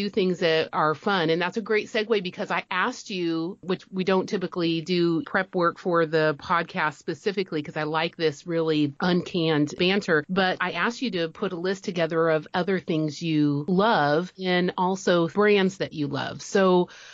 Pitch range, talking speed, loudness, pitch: 160-190 Hz, 180 wpm, -25 LUFS, 175 Hz